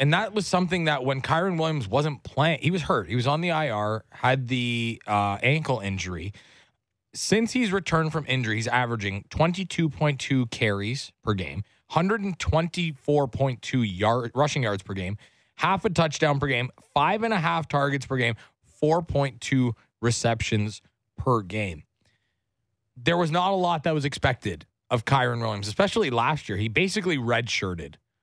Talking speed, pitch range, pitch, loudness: 155 wpm, 110-160 Hz, 130 Hz, -25 LUFS